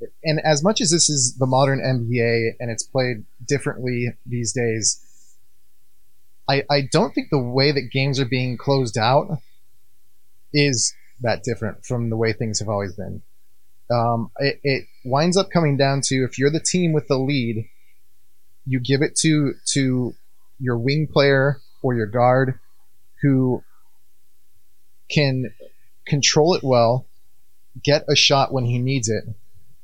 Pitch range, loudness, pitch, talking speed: 115-140 Hz, -20 LUFS, 125 Hz, 150 wpm